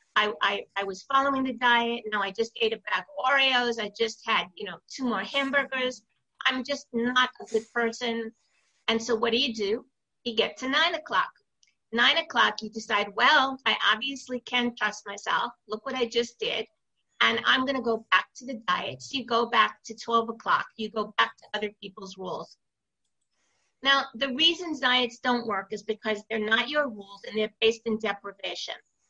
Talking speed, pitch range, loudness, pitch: 195 wpm, 215-260 Hz, -26 LUFS, 235 Hz